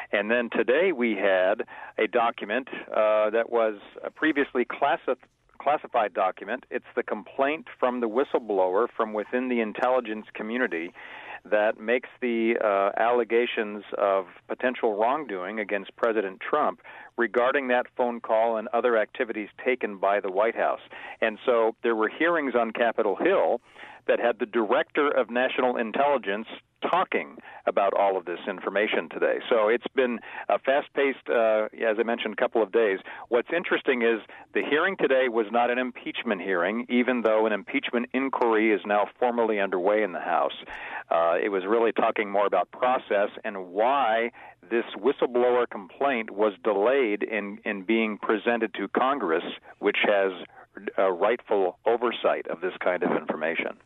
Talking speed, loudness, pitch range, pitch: 155 wpm, -26 LUFS, 105-120 Hz, 115 Hz